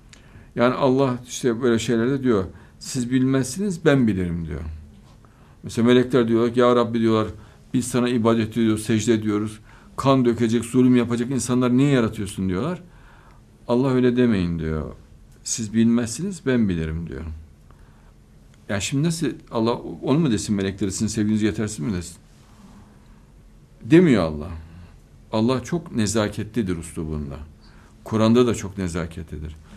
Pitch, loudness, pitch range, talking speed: 115 Hz, -21 LUFS, 90-125 Hz, 130 wpm